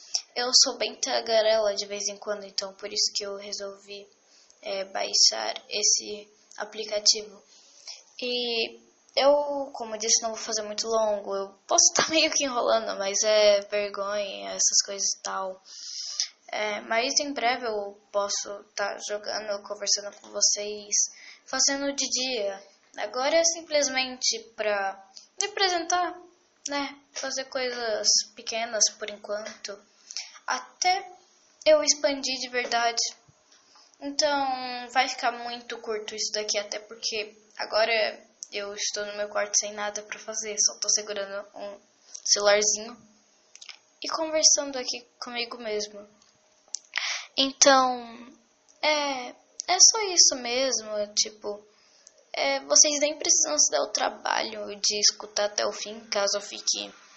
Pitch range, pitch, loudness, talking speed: 205-265 Hz, 220 Hz, -25 LUFS, 130 wpm